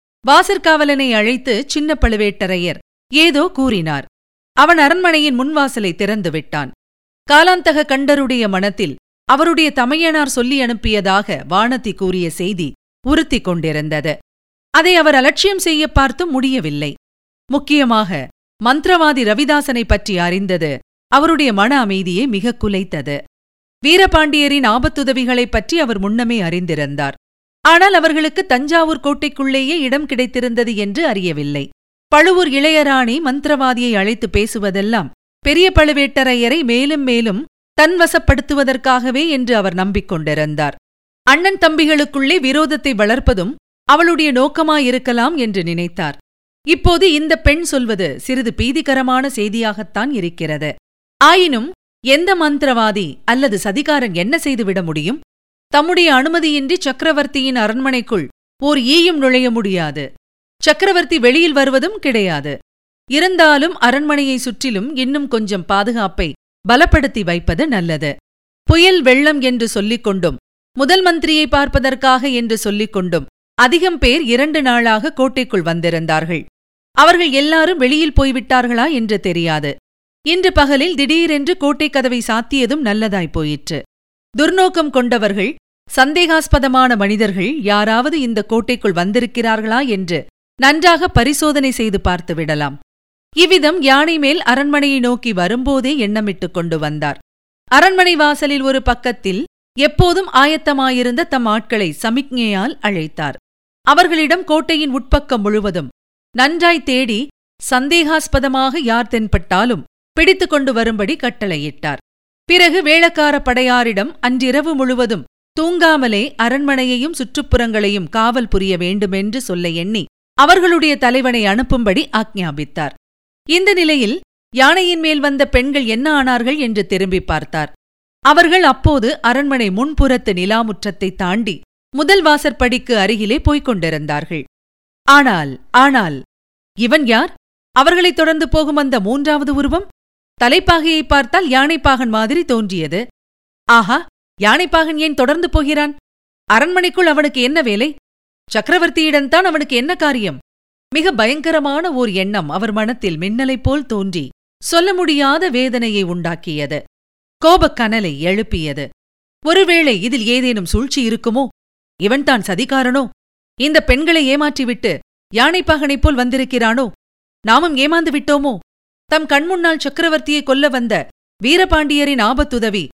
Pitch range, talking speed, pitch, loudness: 210-300 Hz, 100 wpm, 255 Hz, -14 LUFS